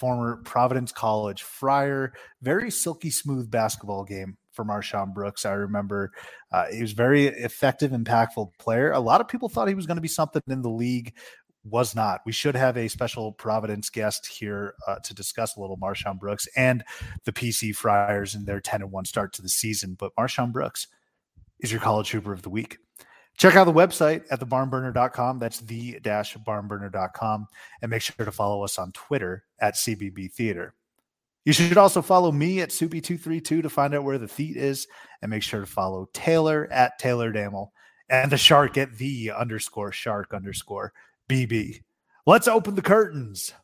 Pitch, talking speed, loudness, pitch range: 115 Hz, 180 wpm, -24 LUFS, 105-140 Hz